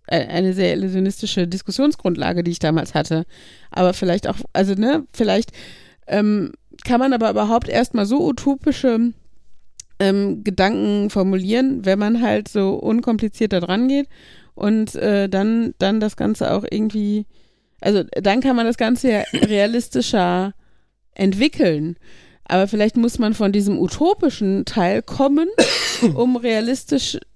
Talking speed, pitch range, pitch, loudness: 130 wpm, 190-240 Hz, 210 Hz, -19 LUFS